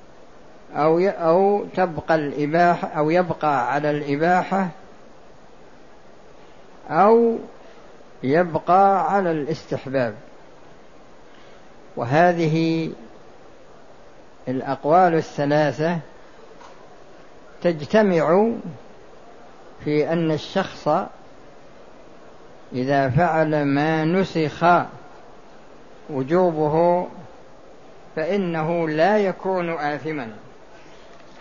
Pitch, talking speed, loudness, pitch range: 165 Hz, 50 wpm, -21 LUFS, 150-180 Hz